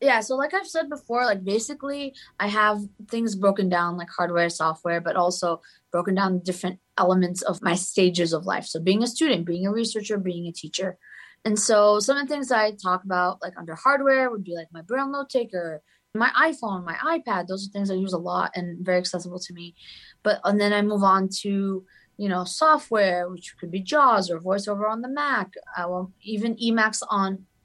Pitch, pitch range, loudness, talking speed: 195 Hz, 180-225 Hz, -24 LUFS, 210 wpm